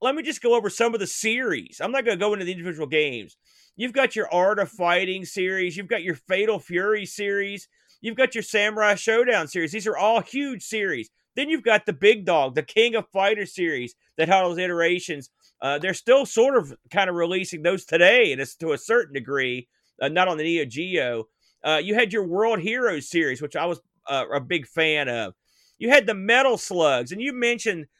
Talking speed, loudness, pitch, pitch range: 220 wpm, -23 LUFS, 195 Hz, 170-225 Hz